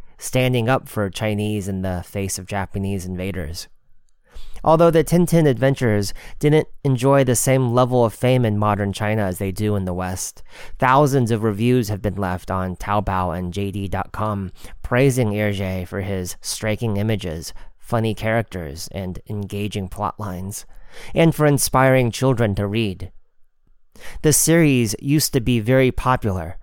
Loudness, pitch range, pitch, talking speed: -20 LUFS, 95-125 Hz, 105 Hz, 145 wpm